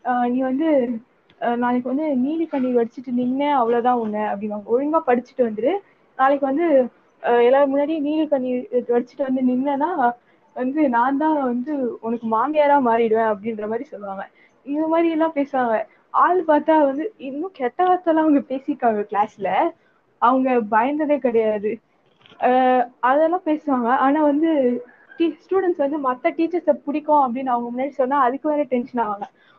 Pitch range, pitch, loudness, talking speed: 240-295 Hz, 260 Hz, -20 LUFS, 135 wpm